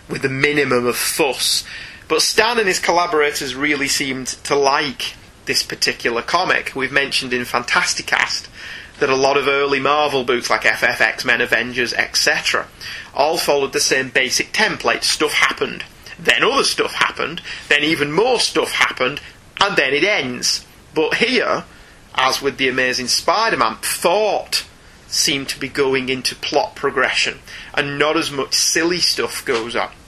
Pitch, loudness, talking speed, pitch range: 140 Hz, -17 LUFS, 155 wpm, 130-145 Hz